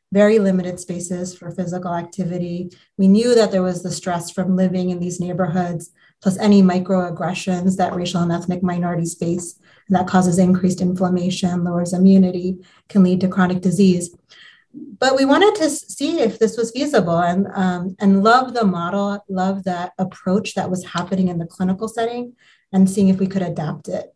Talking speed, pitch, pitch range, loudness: 175 wpm, 185 Hz, 180-195 Hz, -19 LUFS